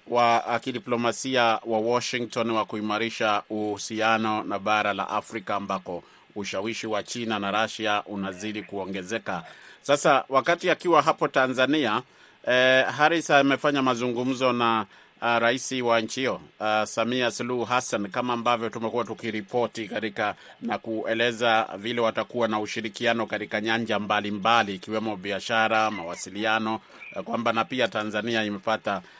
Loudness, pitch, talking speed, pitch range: -25 LUFS, 115 Hz, 120 wpm, 105-120 Hz